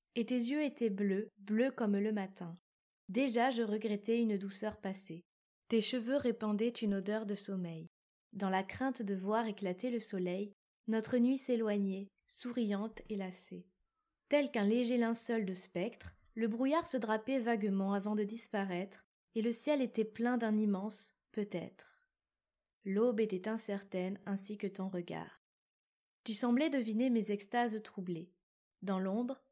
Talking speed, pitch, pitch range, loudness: 150 wpm, 215 Hz, 195-240 Hz, -37 LUFS